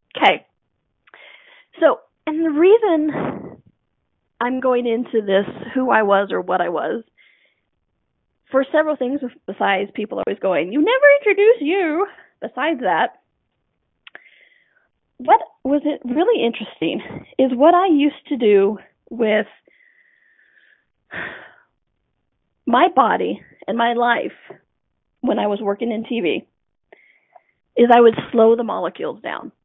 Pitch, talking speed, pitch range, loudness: 275 Hz, 120 wpm, 230-360 Hz, -18 LUFS